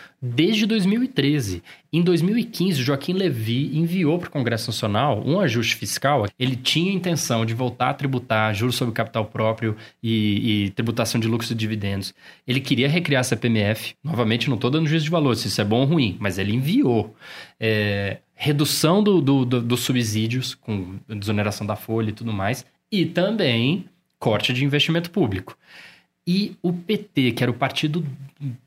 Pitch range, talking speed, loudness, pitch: 110-160 Hz, 170 wpm, -22 LUFS, 130 Hz